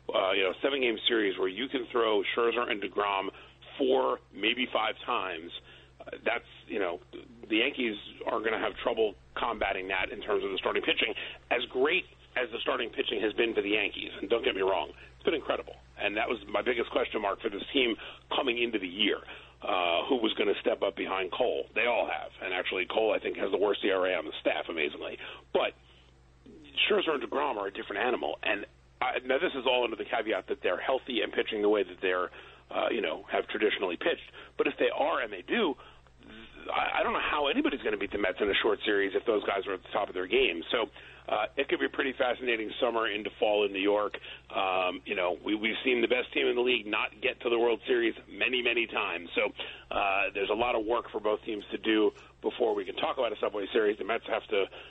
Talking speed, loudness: 240 wpm, -30 LUFS